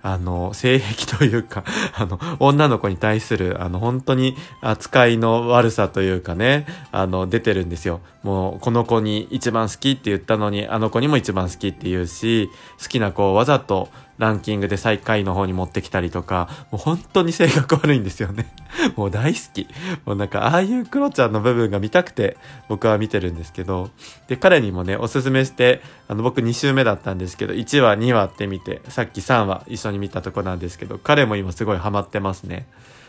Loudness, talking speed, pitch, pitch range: -20 LUFS, 380 characters per minute, 110 Hz, 95-130 Hz